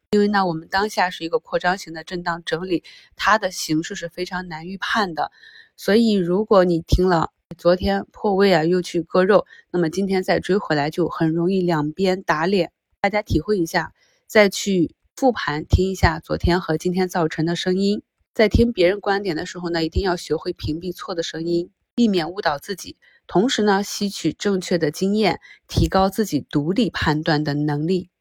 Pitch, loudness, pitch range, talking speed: 180 Hz, -21 LUFS, 165-195 Hz, 280 characters per minute